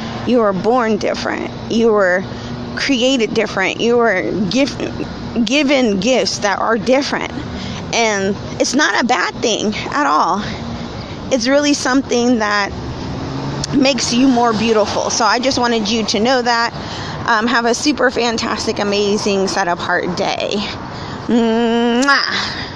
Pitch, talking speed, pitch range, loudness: 235 Hz, 135 wpm, 215-255 Hz, -16 LUFS